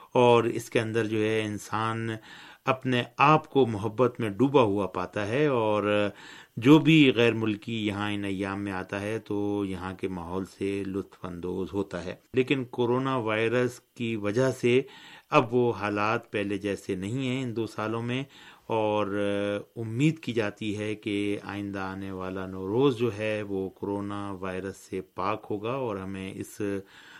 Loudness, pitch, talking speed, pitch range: -28 LUFS, 105 Hz, 165 wpm, 100-120 Hz